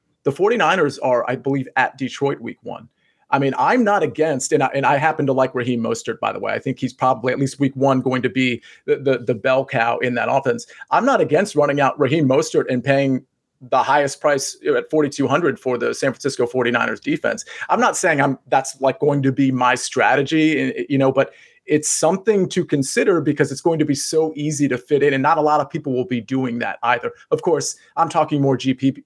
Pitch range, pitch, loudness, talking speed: 130-155 Hz, 140 Hz, -19 LUFS, 225 wpm